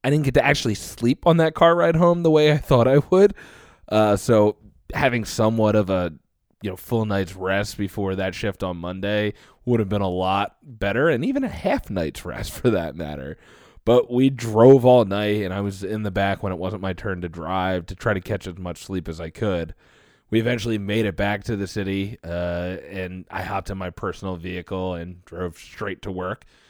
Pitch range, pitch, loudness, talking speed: 95-115 Hz, 100 Hz, -22 LUFS, 220 wpm